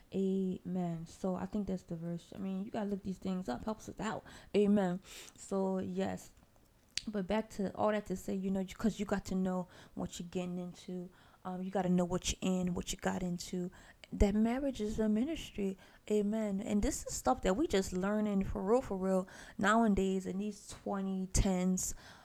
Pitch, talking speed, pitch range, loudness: 195 Hz, 195 wpm, 185-210 Hz, -36 LUFS